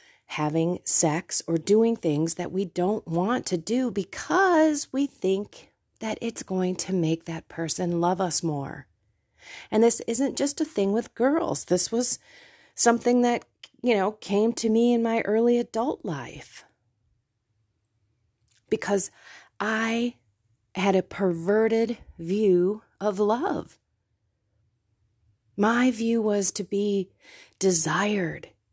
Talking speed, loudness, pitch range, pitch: 125 wpm, -25 LUFS, 160-230 Hz, 195 Hz